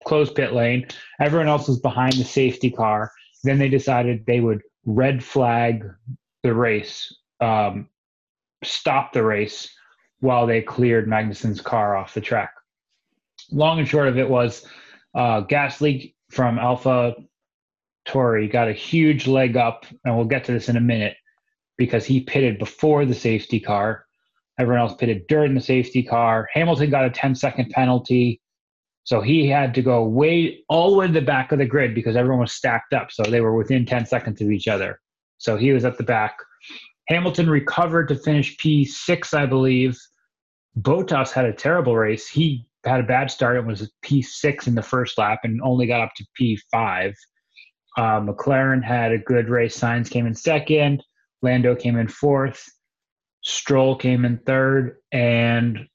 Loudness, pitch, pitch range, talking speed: -20 LUFS, 125 Hz, 115-140 Hz, 175 wpm